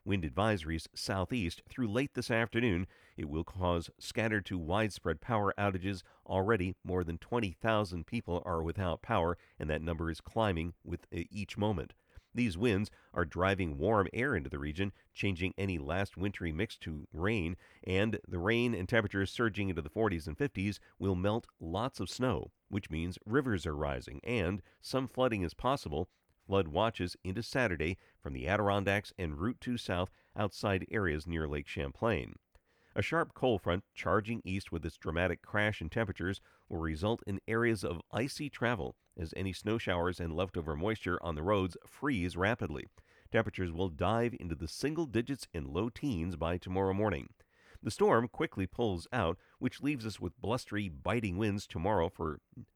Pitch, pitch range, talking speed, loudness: 95 Hz, 85-110 Hz, 165 wpm, -35 LUFS